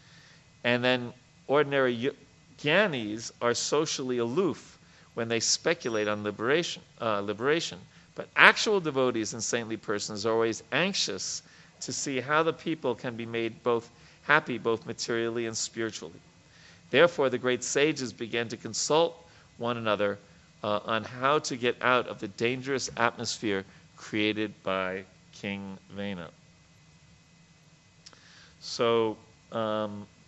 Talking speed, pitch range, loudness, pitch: 125 wpm, 110-130 Hz, -28 LUFS, 115 Hz